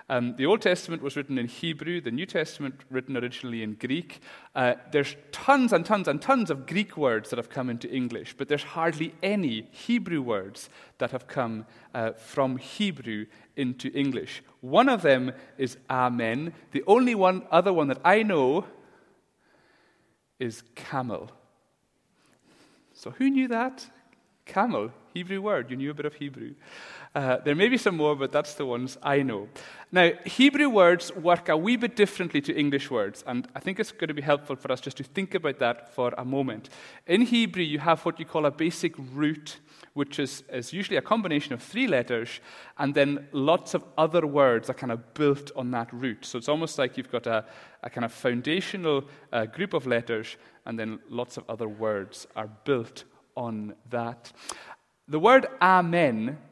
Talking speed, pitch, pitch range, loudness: 185 wpm, 145 Hz, 125-175 Hz, -27 LUFS